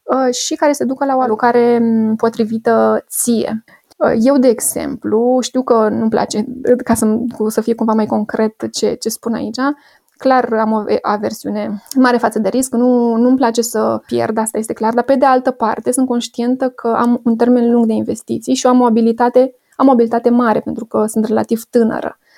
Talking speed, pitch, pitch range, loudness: 185 wpm, 235 Hz, 225-250 Hz, -15 LUFS